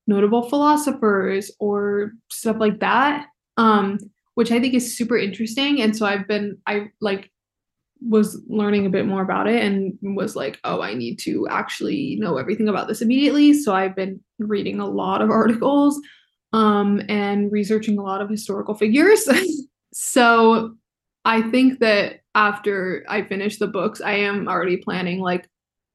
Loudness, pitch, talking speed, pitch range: -20 LUFS, 210 Hz, 160 wpm, 200-230 Hz